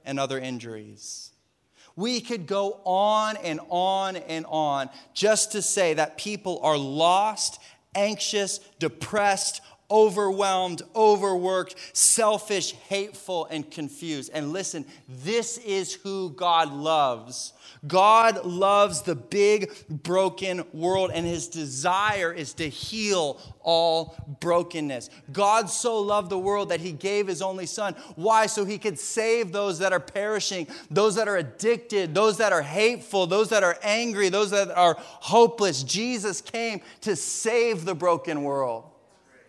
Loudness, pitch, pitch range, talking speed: -24 LUFS, 190 Hz, 160-210 Hz, 135 wpm